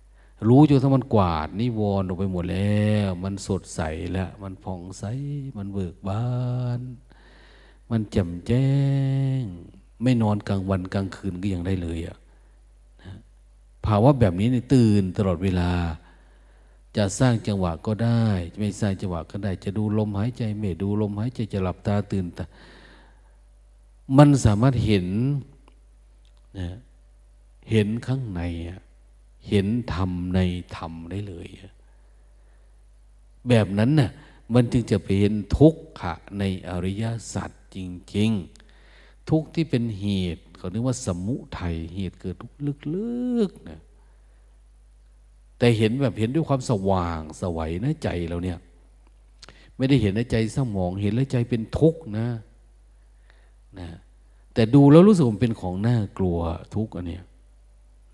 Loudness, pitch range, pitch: -24 LUFS, 85-115 Hz, 100 Hz